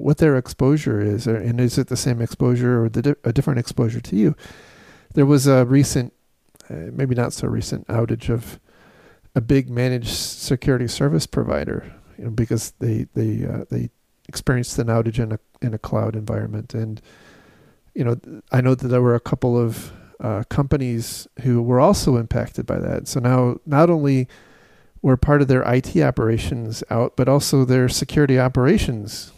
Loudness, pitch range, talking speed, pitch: -20 LUFS, 115-135 Hz, 180 wpm, 125 Hz